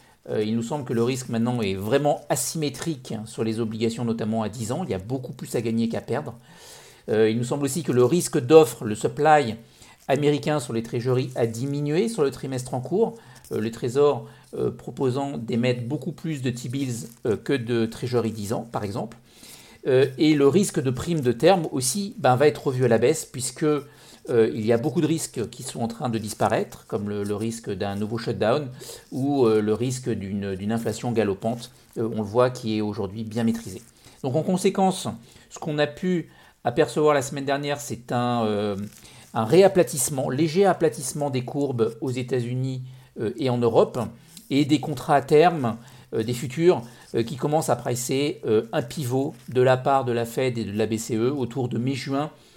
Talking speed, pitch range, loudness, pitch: 195 wpm, 115-145 Hz, -24 LUFS, 125 Hz